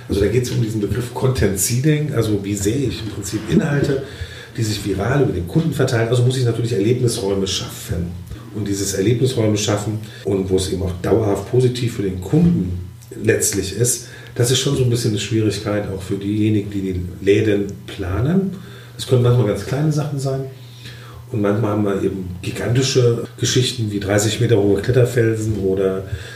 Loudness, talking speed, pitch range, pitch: -19 LUFS, 180 wpm, 100-125 Hz, 110 Hz